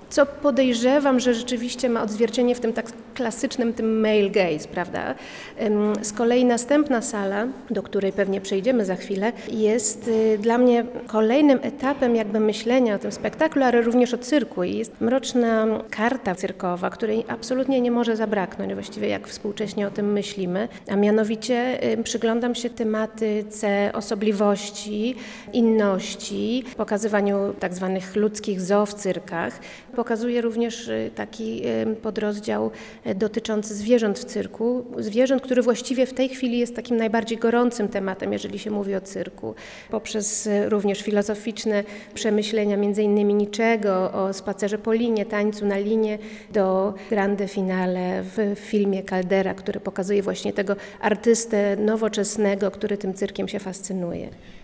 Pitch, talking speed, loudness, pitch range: 215 Hz, 135 wpm, -23 LUFS, 200-235 Hz